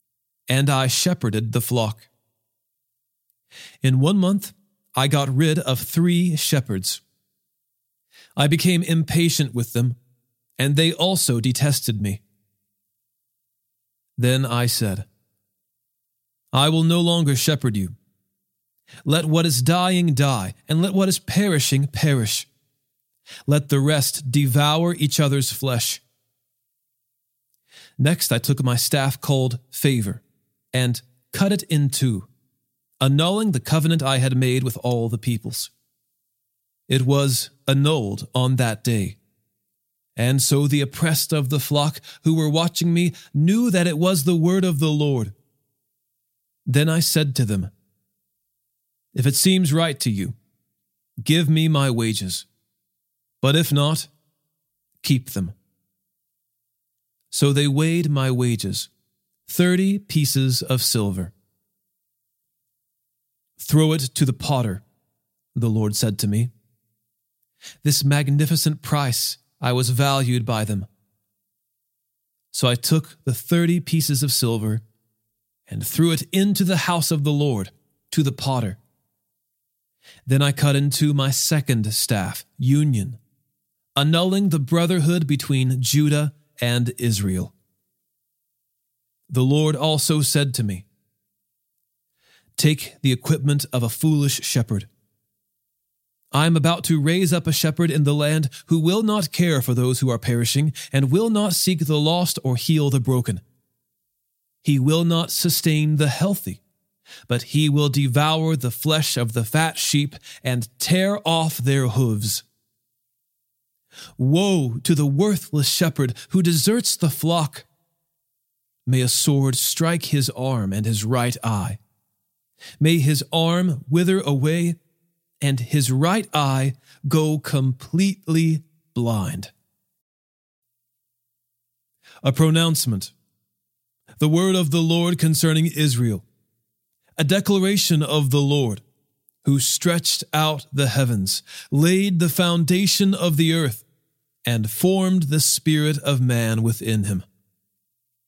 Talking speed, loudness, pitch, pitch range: 125 wpm, -20 LUFS, 135 Hz, 120-160 Hz